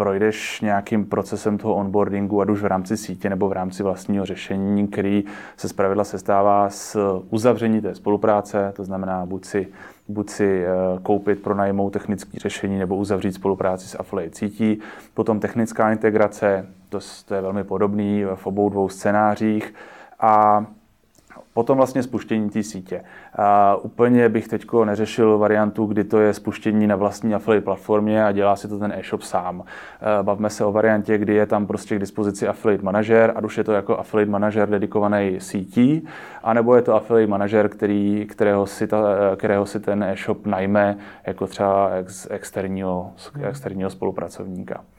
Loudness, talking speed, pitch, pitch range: -21 LUFS, 155 wpm, 105 Hz, 100-105 Hz